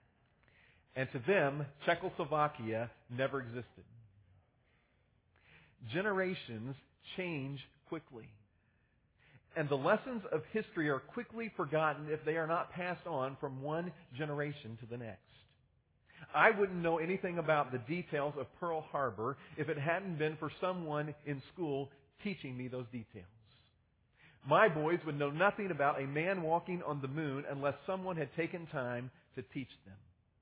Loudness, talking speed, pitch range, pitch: -37 LUFS, 140 wpm, 125-170 Hz, 145 Hz